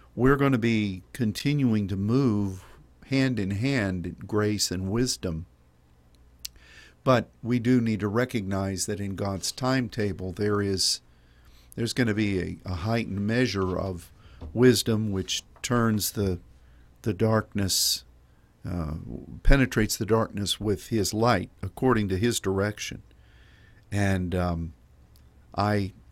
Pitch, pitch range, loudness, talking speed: 100 Hz, 90-115 Hz, -26 LUFS, 125 wpm